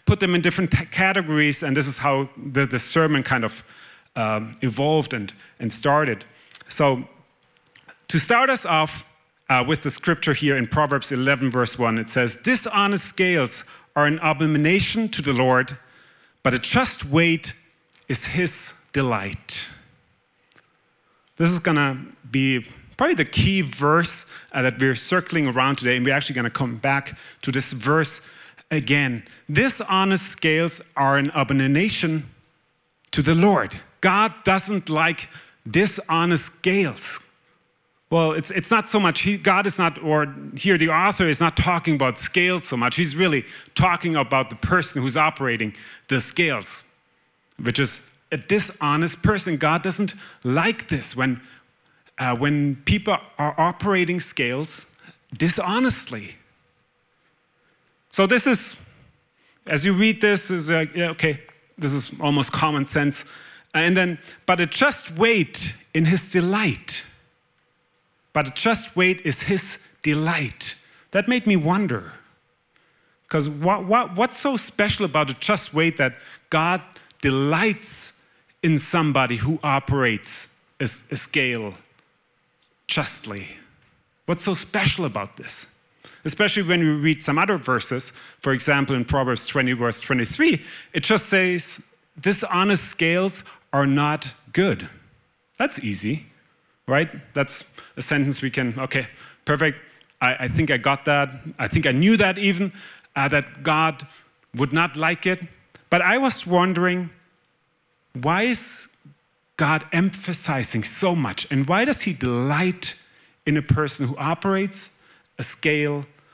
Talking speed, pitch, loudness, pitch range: 140 wpm, 155 Hz, -21 LUFS, 135-180 Hz